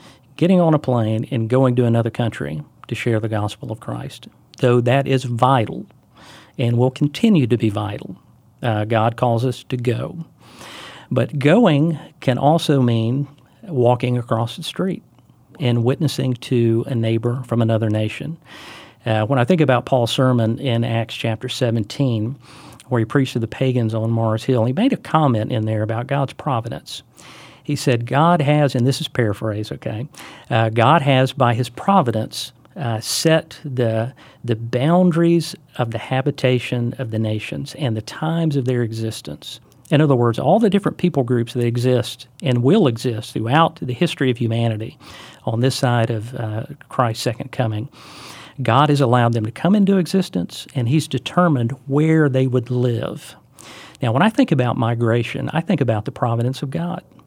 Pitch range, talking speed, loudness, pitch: 115-145 Hz, 170 wpm, -19 LUFS, 125 Hz